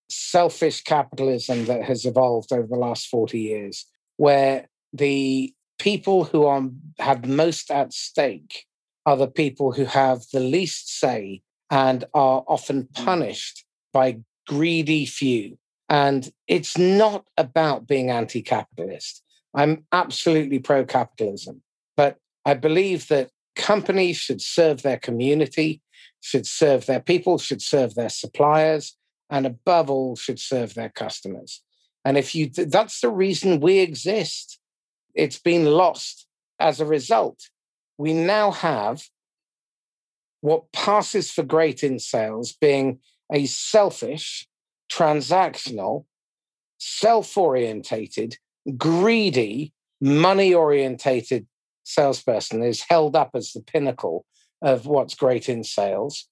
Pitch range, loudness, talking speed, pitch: 130-165 Hz, -22 LUFS, 120 wpm, 145 Hz